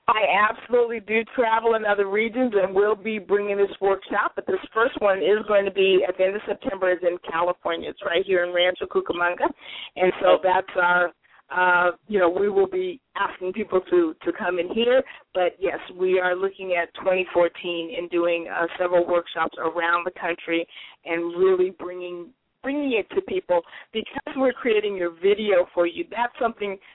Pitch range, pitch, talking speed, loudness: 175-220 Hz, 190 Hz, 185 wpm, -23 LUFS